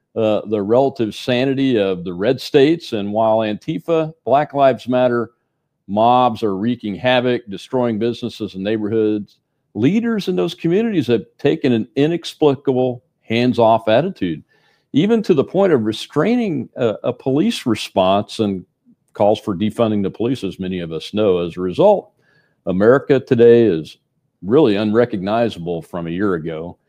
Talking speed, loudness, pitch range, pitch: 145 wpm, -17 LUFS, 105-135 Hz, 115 Hz